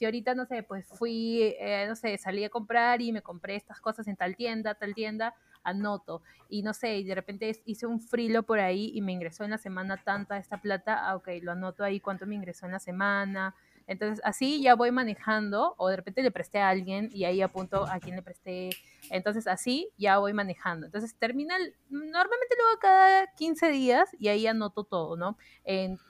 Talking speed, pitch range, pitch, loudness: 210 wpm, 190-230 Hz, 210 Hz, -29 LUFS